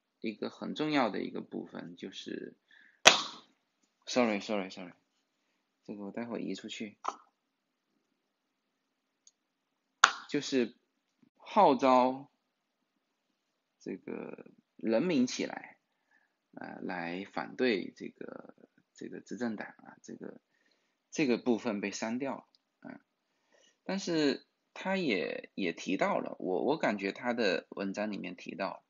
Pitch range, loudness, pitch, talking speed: 100-155 Hz, -32 LUFS, 125 Hz, 185 characters per minute